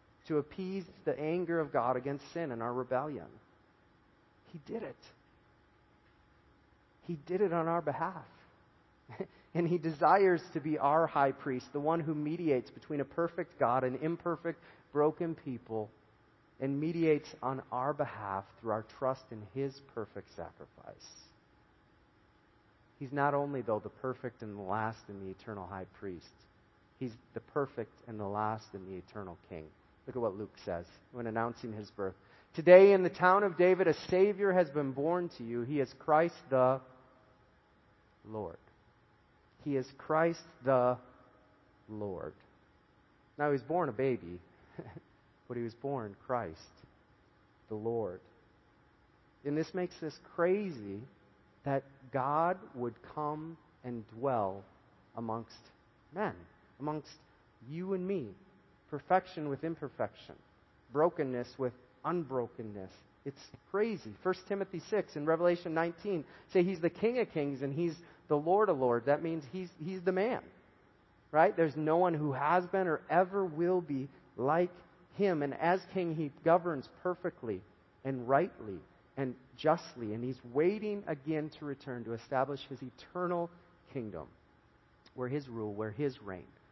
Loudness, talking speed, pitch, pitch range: -34 LUFS, 145 wpm, 140 Hz, 115-165 Hz